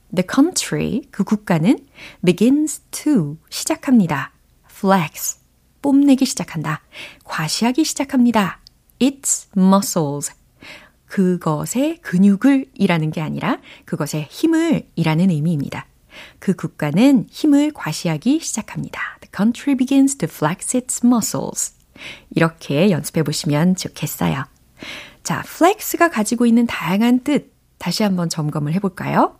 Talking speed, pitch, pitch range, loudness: 345 characters per minute, 200 Hz, 160-265 Hz, -18 LUFS